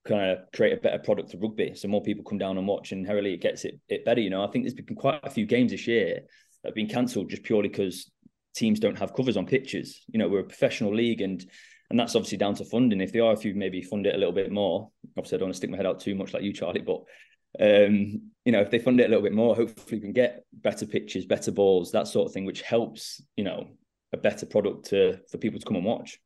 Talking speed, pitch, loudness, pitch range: 285 wpm, 105 Hz, -27 LUFS, 100-120 Hz